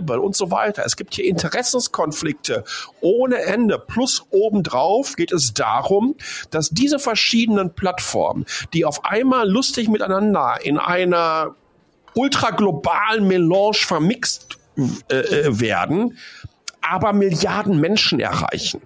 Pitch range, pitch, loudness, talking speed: 180-240 Hz, 205 Hz, -19 LUFS, 110 wpm